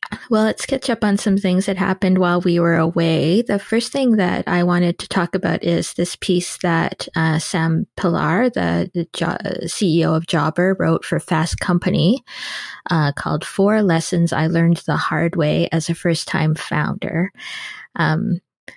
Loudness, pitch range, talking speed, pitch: -19 LUFS, 165-195 Hz, 175 wpm, 175 Hz